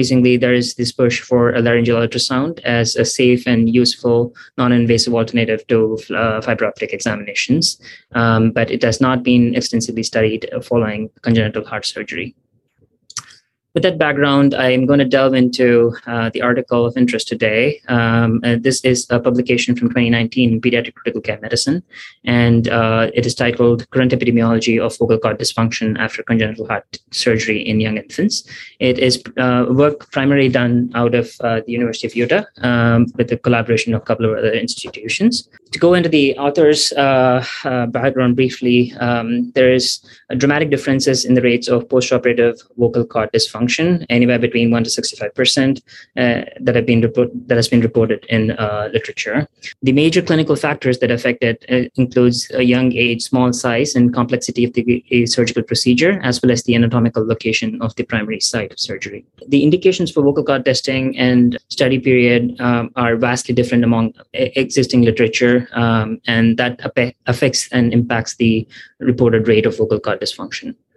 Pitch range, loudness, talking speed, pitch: 115-125 Hz, -15 LUFS, 170 wpm, 120 Hz